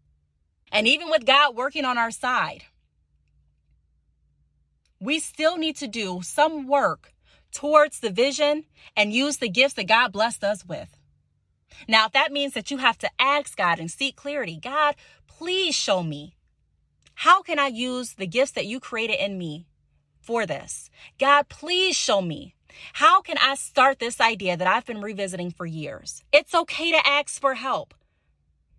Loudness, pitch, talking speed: -22 LUFS, 235 Hz, 165 wpm